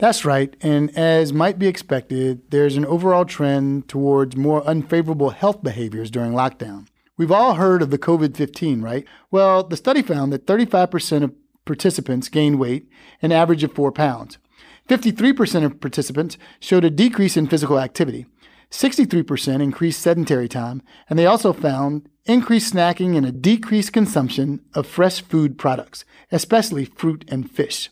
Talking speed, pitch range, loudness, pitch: 155 wpm, 140-185 Hz, -19 LUFS, 155 Hz